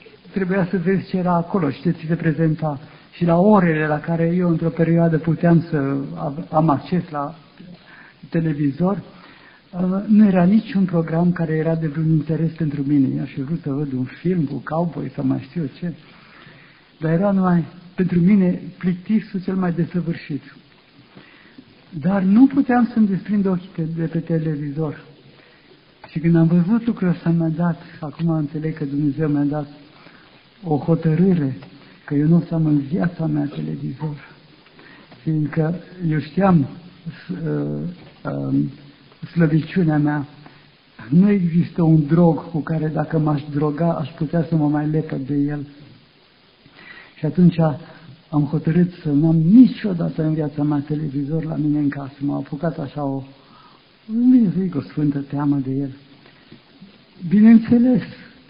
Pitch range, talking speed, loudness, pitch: 150-175 Hz, 150 wpm, -19 LUFS, 160 Hz